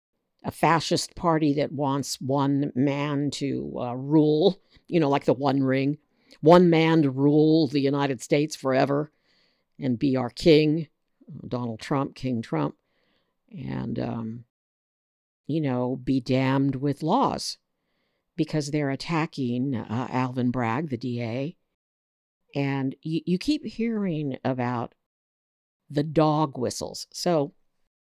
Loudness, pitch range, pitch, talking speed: -25 LUFS, 130-155 Hz, 140 Hz, 125 wpm